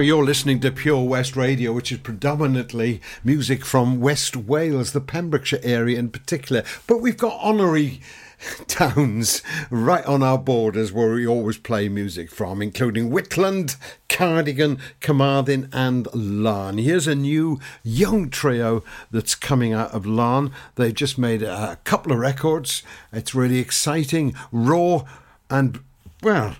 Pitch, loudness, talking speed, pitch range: 130 Hz, -21 LUFS, 140 wpm, 115-150 Hz